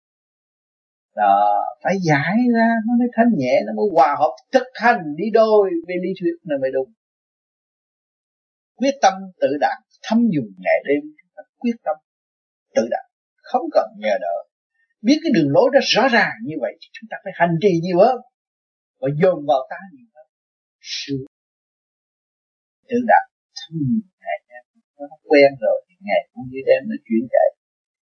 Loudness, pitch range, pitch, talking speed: -19 LUFS, 155-255 Hz, 205 Hz, 170 wpm